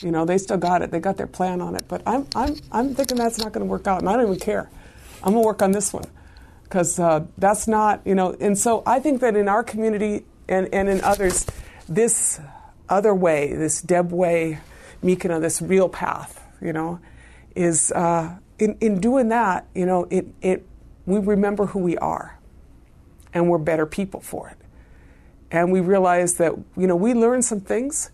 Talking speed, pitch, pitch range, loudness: 205 wpm, 185 Hz, 170-210 Hz, -21 LUFS